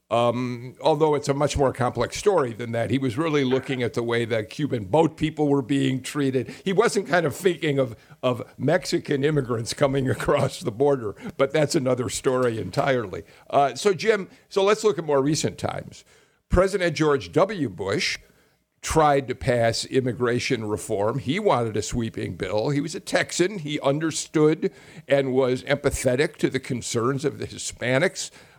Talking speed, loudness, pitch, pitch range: 170 wpm, -24 LUFS, 140 Hz, 125-155 Hz